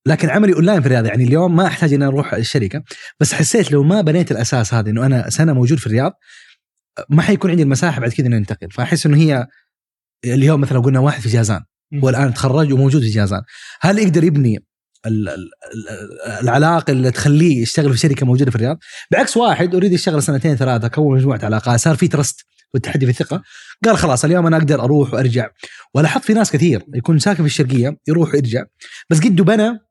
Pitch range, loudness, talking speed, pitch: 125-165 Hz, -15 LUFS, 190 wpm, 145 Hz